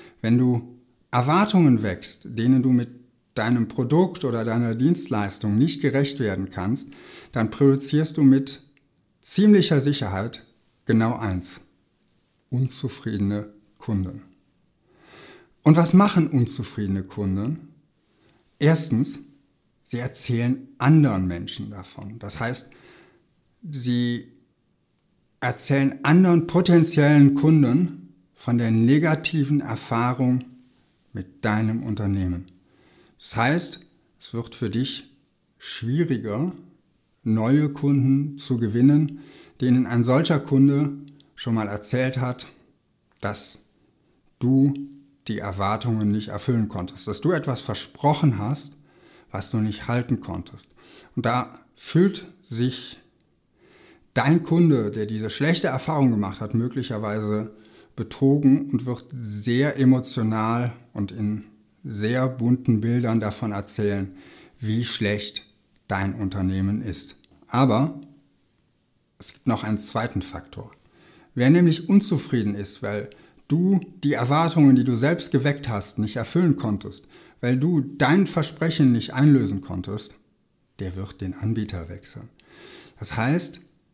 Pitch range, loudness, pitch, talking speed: 105-145 Hz, -23 LUFS, 125 Hz, 110 wpm